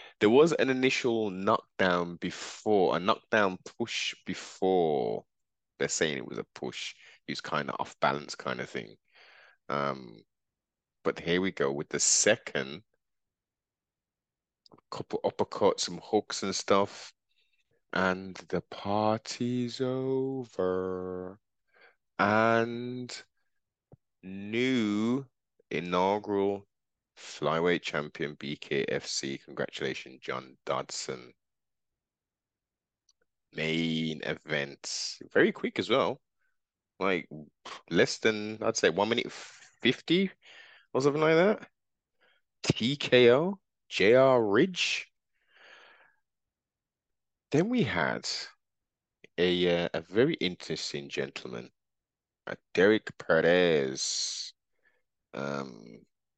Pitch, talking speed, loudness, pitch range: 100 Hz, 90 wpm, -29 LUFS, 85-120 Hz